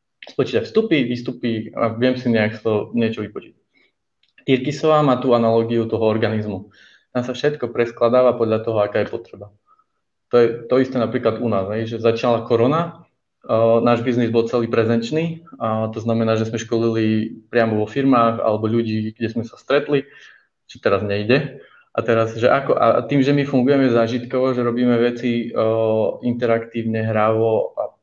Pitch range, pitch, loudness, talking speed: 110-125 Hz, 115 Hz, -19 LUFS, 165 wpm